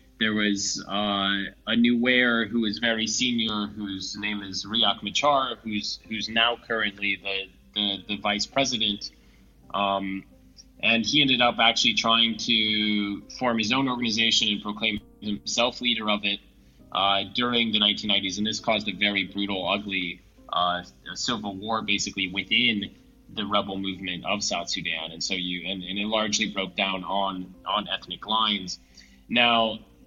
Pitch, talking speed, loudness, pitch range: 105 Hz, 160 wpm, -24 LUFS, 95-115 Hz